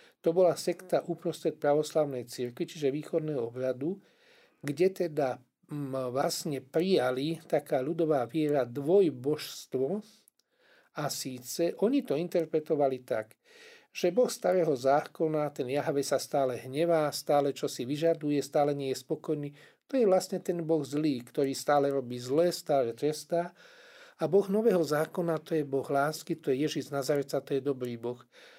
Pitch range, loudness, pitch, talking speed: 140-175 Hz, -30 LUFS, 155 Hz, 145 wpm